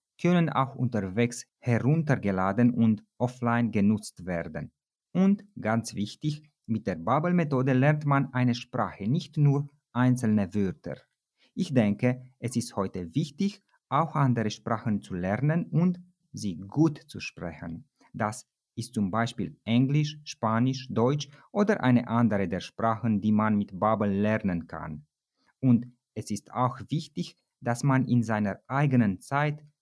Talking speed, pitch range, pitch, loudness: 135 wpm, 105-145 Hz, 120 Hz, -28 LUFS